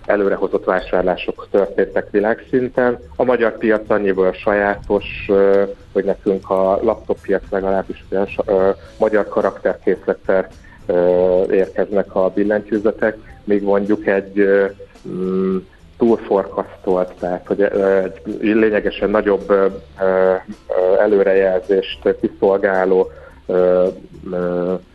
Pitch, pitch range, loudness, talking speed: 95 Hz, 95-105 Hz, -17 LUFS, 75 wpm